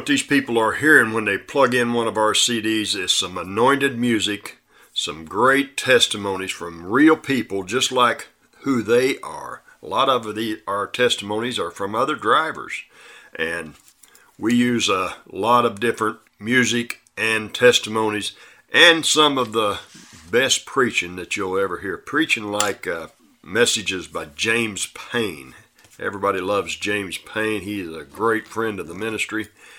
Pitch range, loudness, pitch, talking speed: 105-125 Hz, -20 LUFS, 110 Hz, 155 wpm